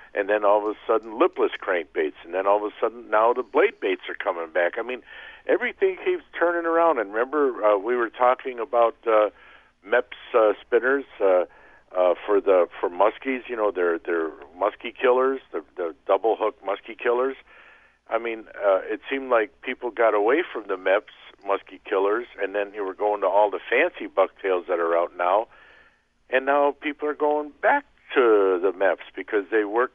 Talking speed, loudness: 190 wpm, -24 LUFS